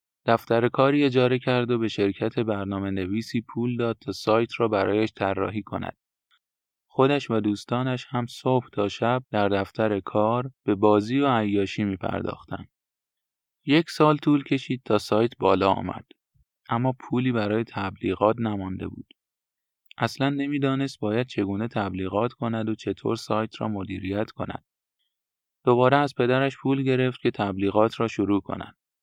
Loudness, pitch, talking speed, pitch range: -25 LUFS, 115 Hz, 145 wpm, 100-130 Hz